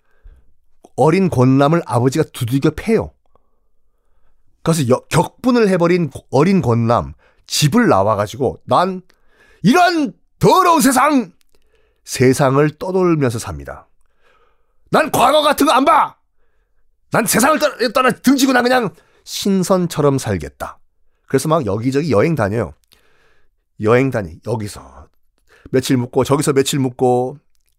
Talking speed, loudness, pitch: 240 characters per minute, -15 LUFS, 145 Hz